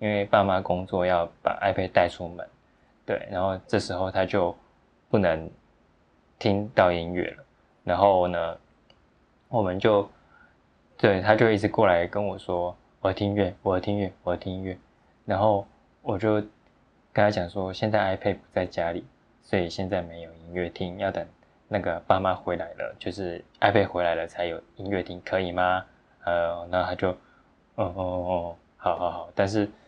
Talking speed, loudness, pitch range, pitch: 255 characters per minute, -26 LUFS, 90-100 Hz, 95 Hz